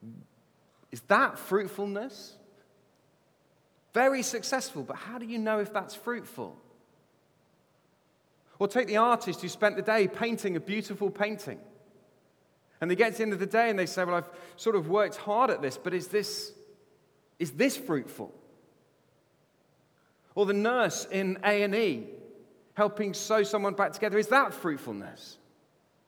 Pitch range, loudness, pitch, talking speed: 195-225 Hz, -29 LUFS, 205 Hz, 150 wpm